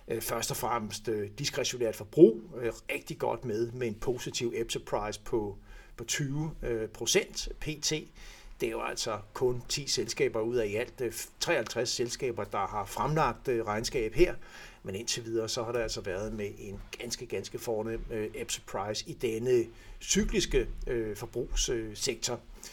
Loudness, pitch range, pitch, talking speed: -32 LUFS, 110-140 Hz, 115 Hz, 140 wpm